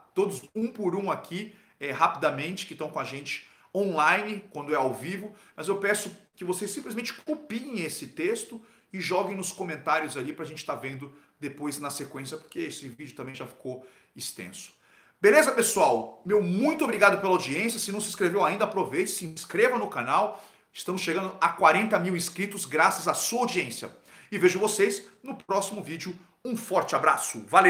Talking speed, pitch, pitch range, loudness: 180 wpm, 190 Hz, 155-210 Hz, -27 LUFS